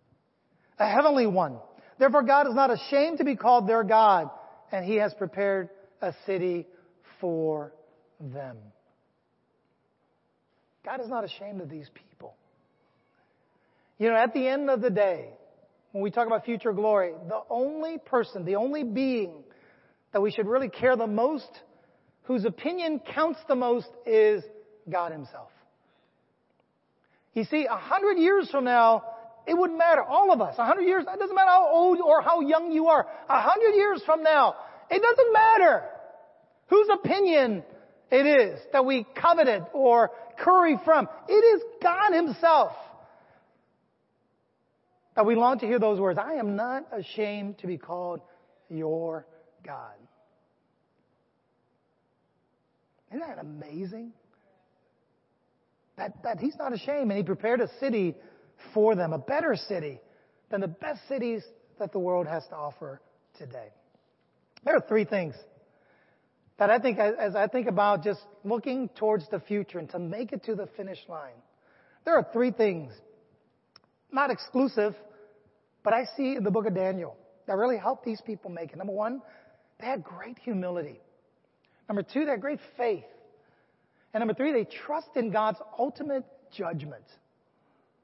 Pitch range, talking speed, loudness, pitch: 200-290 Hz, 150 wpm, -25 LUFS, 230 Hz